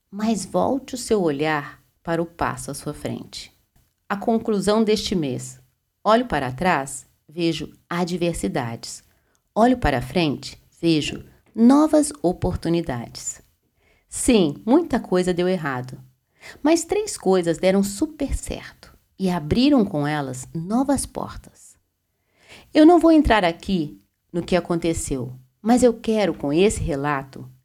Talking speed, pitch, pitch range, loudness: 125 wpm, 175 Hz, 145-225 Hz, -21 LUFS